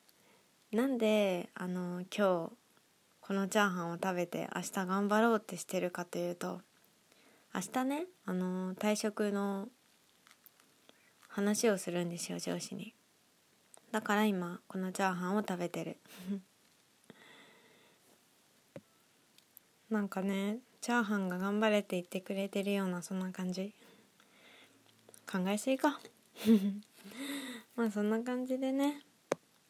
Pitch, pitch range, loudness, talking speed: 200 Hz, 185-225 Hz, -35 LUFS, 230 characters per minute